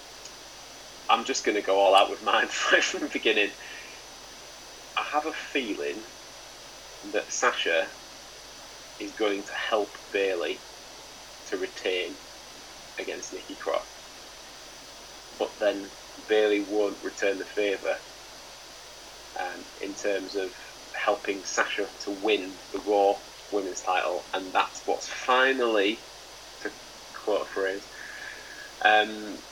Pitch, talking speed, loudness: 110 Hz, 115 wpm, -27 LUFS